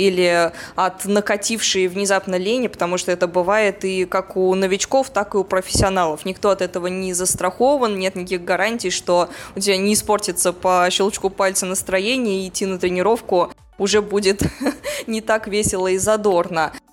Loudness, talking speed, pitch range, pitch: -19 LUFS, 160 wpm, 185-210 Hz, 190 Hz